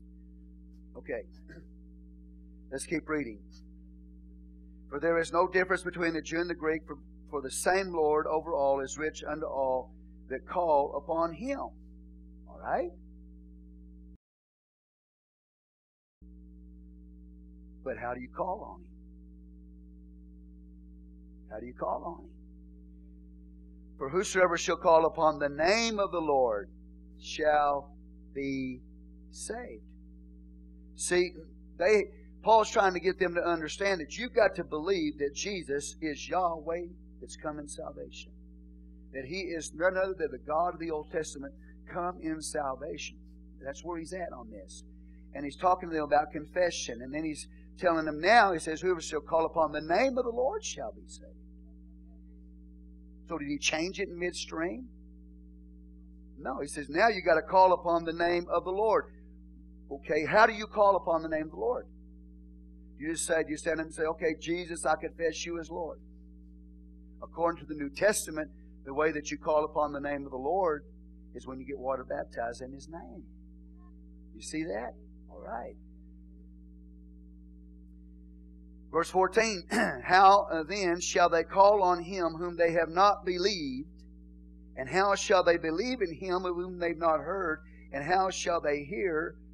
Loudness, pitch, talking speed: -30 LUFS, 140 Hz, 160 wpm